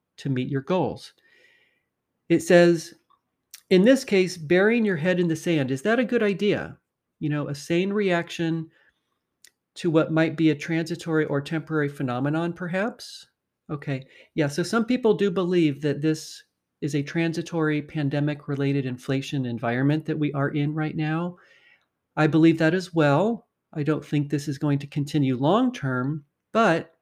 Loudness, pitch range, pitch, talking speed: -24 LUFS, 145-180 Hz, 160 Hz, 160 wpm